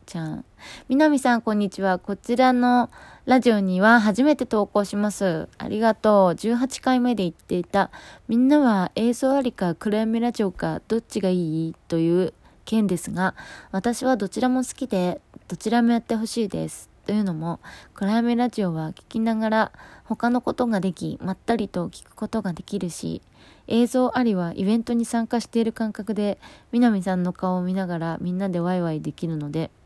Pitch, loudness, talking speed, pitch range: 215 Hz, -23 LUFS, 350 characters per minute, 185-235 Hz